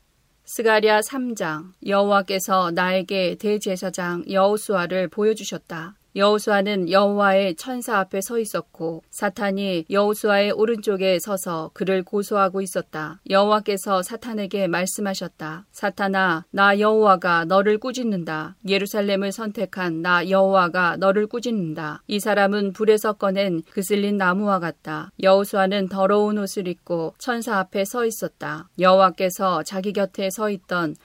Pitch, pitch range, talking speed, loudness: 195 Hz, 180-205 Hz, 315 characters per minute, -21 LUFS